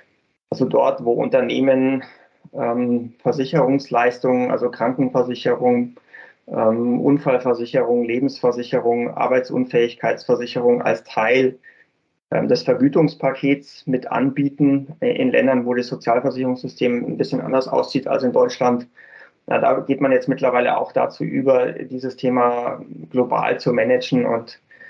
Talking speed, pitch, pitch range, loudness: 115 wpm, 130 Hz, 120-140 Hz, -19 LUFS